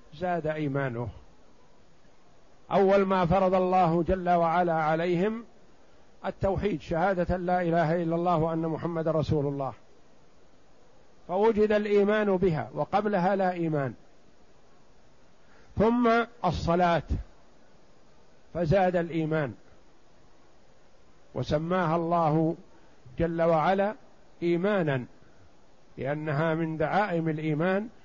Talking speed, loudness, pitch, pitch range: 80 wpm, -27 LUFS, 170 Hz, 155-190 Hz